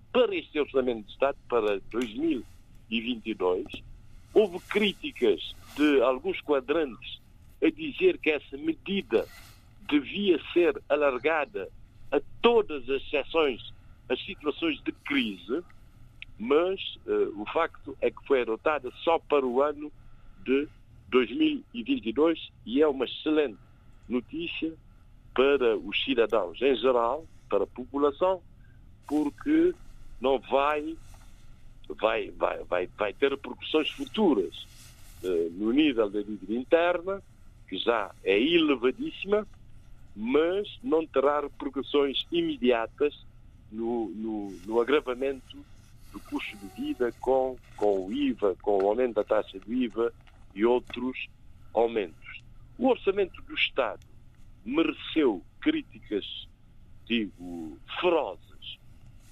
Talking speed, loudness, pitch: 110 wpm, -28 LUFS, 145 Hz